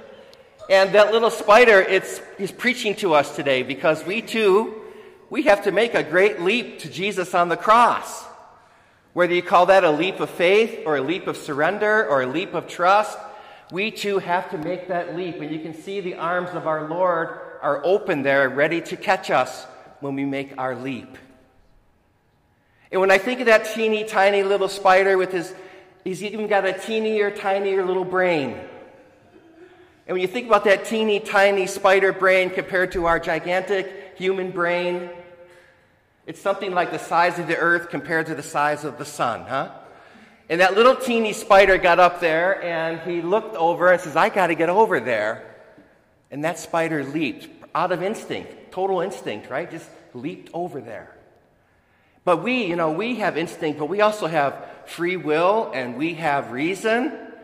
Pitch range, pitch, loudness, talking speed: 165-200 Hz, 185 Hz, -20 LUFS, 180 wpm